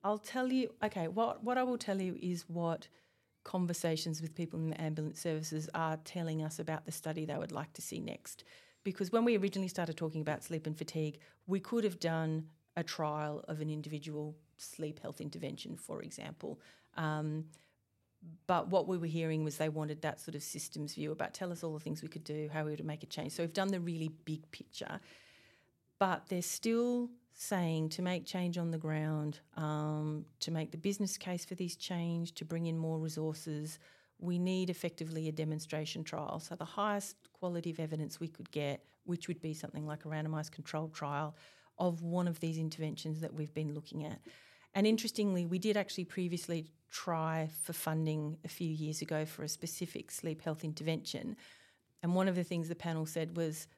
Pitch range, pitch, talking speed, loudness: 155-180 Hz, 160 Hz, 195 wpm, -38 LUFS